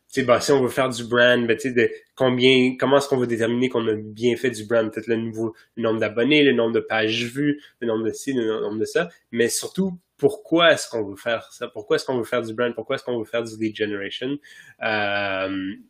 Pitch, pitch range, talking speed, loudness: 120 Hz, 110-130 Hz, 240 wpm, -22 LUFS